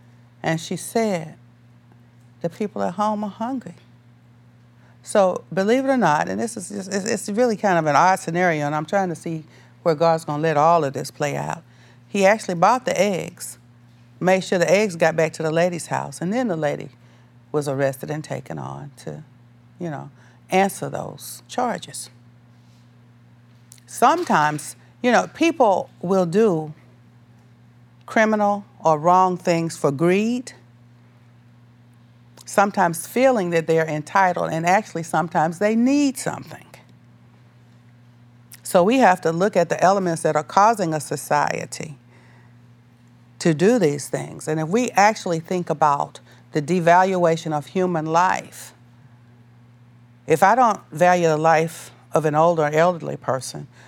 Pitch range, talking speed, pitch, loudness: 120-185 Hz, 150 wpm, 155 Hz, -20 LUFS